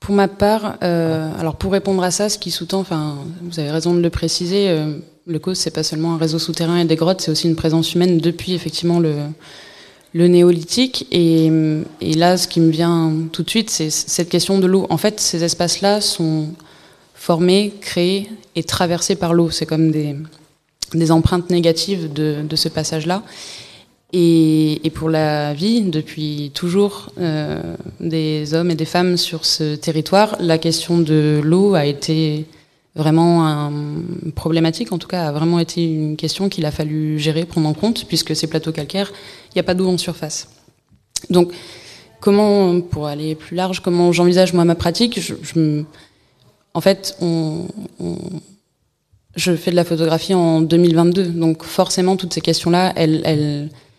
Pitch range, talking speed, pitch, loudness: 155-180 Hz, 175 wpm, 165 Hz, -17 LUFS